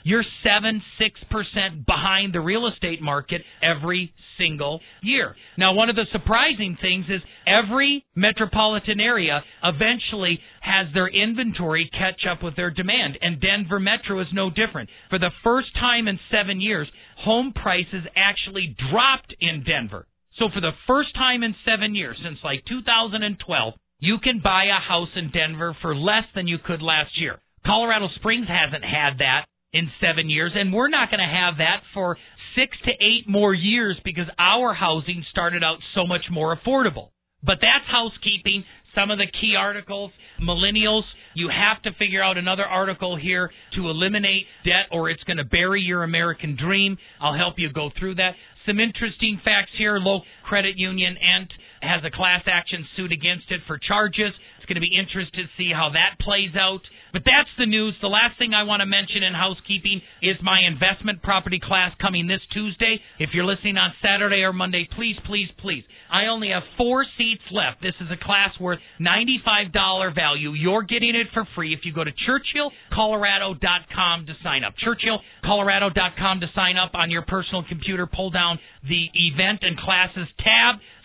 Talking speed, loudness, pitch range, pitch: 175 wpm, -21 LUFS, 175-210 Hz, 190 Hz